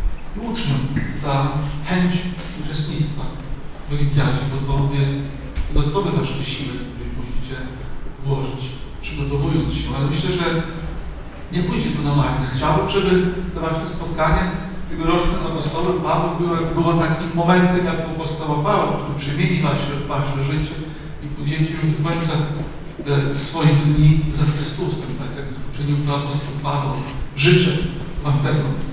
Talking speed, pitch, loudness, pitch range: 140 wpm, 150 Hz, -20 LUFS, 140-165 Hz